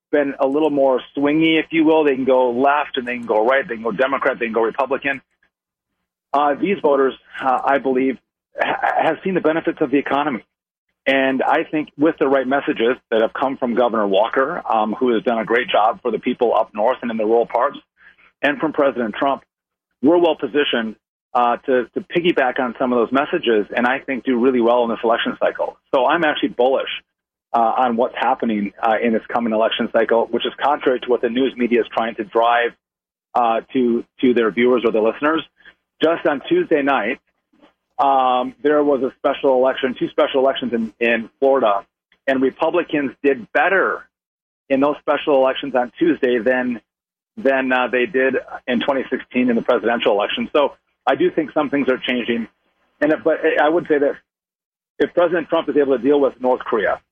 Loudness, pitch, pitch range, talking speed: -18 LUFS, 135 Hz, 120-150 Hz, 200 wpm